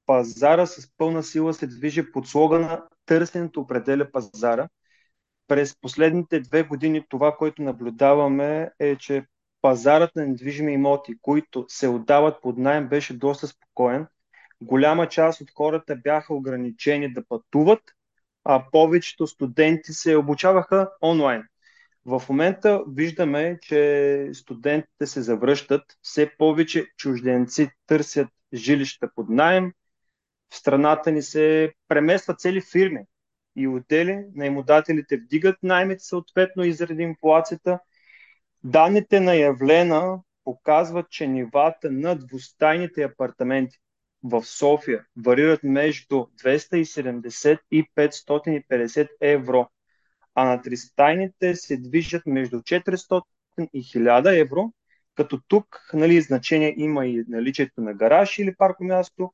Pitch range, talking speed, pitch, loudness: 135-165 Hz, 115 wpm, 150 Hz, -22 LUFS